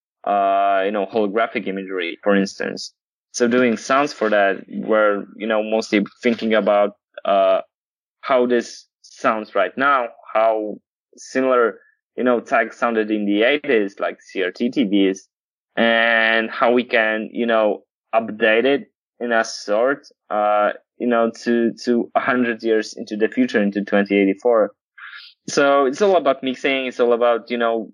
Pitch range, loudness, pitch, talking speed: 105-120 Hz, -19 LUFS, 115 Hz, 155 wpm